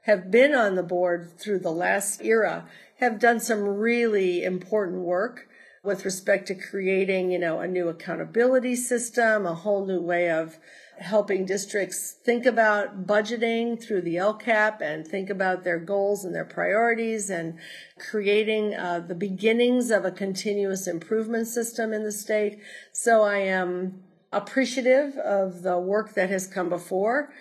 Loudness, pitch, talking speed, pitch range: -25 LUFS, 200 Hz, 155 wpm, 185-225 Hz